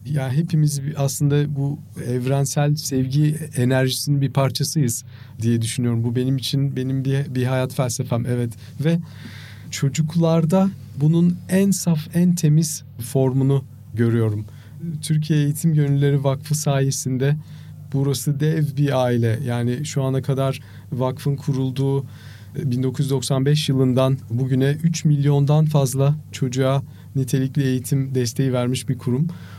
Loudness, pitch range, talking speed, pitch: -21 LUFS, 125-145 Hz, 120 wpm, 135 Hz